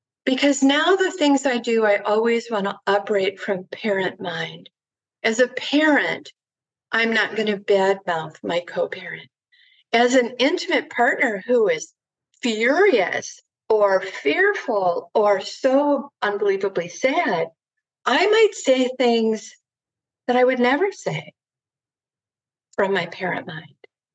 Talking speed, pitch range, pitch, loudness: 125 wpm, 195-285 Hz, 225 Hz, -20 LUFS